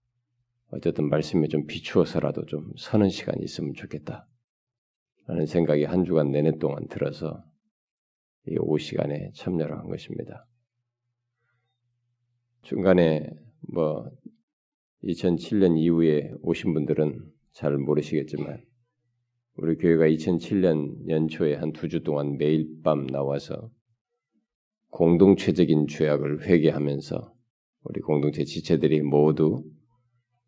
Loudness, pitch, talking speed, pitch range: -25 LUFS, 85 Hz, 230 characters per minute, 75-120 Hz